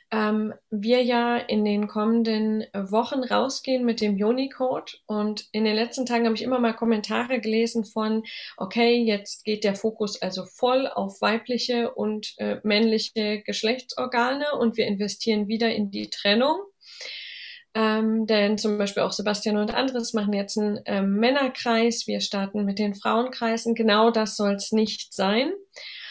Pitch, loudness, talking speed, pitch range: 220 Hz, -24 LUFS, 155 wpm, 210-240 Hz